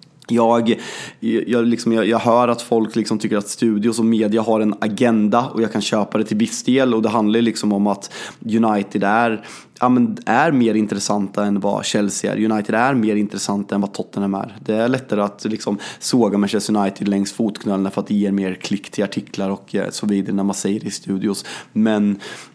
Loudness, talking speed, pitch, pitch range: -19 LUFS, 205 wpm, 110 Hz, 100-115 Hz